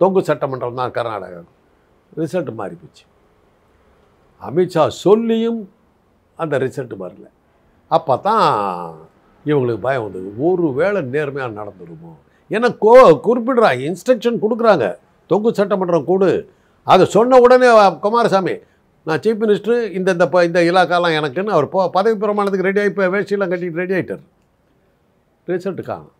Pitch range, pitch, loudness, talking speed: 150-210 Hz, 185 Hz, -16 LUFS, 110 wpm